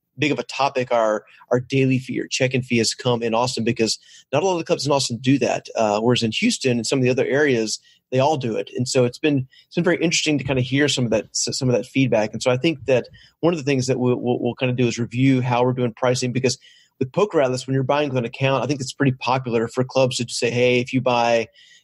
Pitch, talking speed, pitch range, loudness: 125 Hz, 285 wpm, 120-135 Hz, -21 LUFS